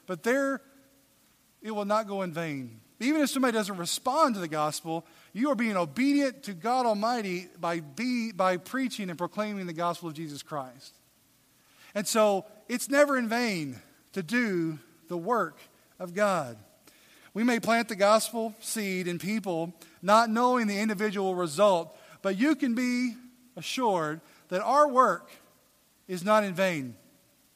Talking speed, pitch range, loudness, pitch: 155 wpm, 170-240 Hz, -28 LUFS, 205 Hz